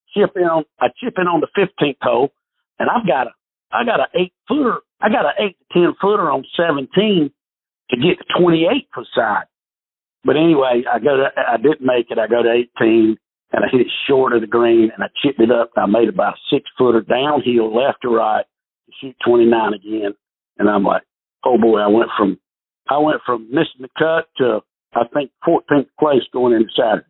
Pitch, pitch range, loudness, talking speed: 130 Hz, 115-165 Hz, -16 LUFS, 215 wpm